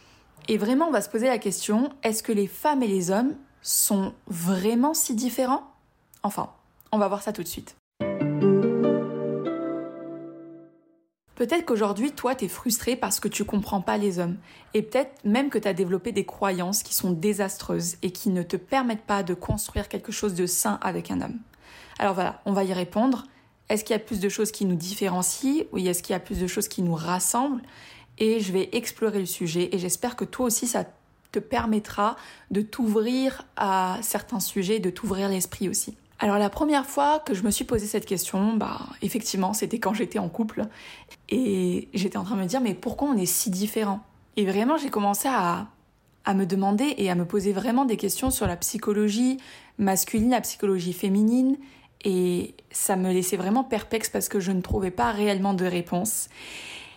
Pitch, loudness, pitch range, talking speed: 205 Hz, -26 LUFS, 190-230 Hz, 195 wpm